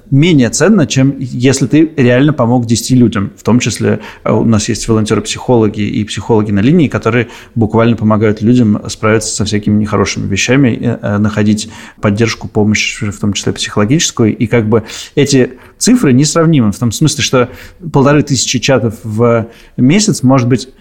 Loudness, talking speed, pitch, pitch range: -11 LUFS, 155 wpm, 115 Hz, 110-130 Hz